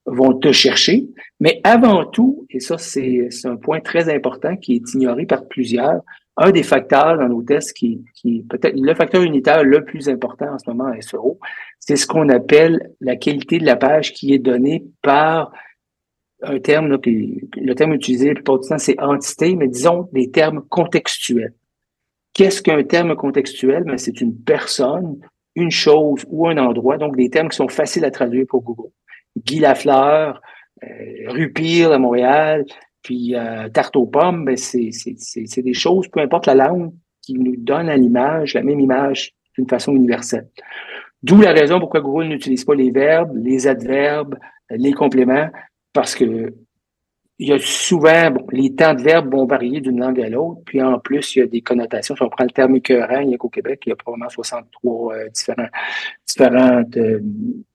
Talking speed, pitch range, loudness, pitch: 190 wpm, 125-160 Hz, -16 LUFS, 140 Hz